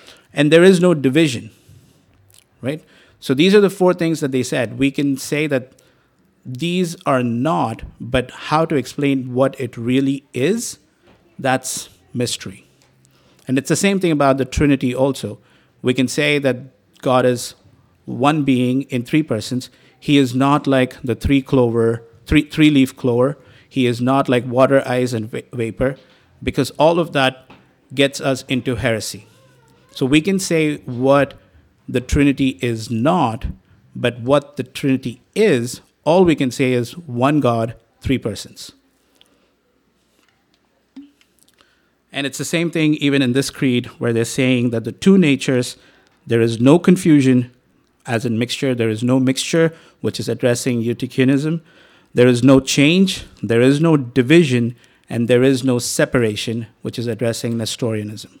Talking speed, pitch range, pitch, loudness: 155 wpm, 120-145 Hz, 130 Hz, -17 LUFS